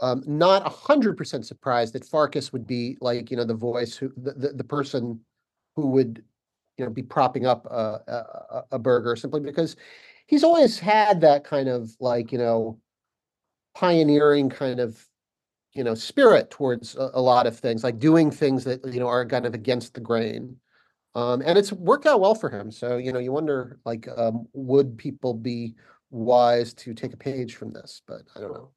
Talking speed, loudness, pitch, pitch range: 195 wpm, -23 LUFS, 130 Hz, 120-145 Hz